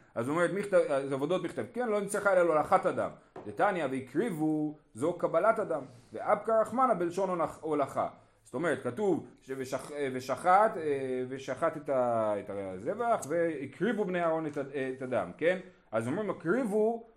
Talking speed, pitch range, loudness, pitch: 135 wpm, 135-190 Hz, -31 LUFS, 155 Hz